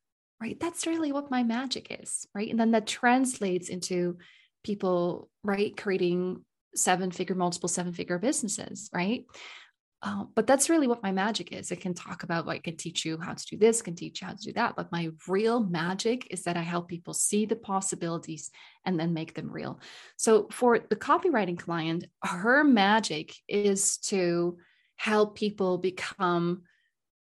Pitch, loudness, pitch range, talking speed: 190 Hz, -29 LUFS, 175-225 Hz, 170 wpm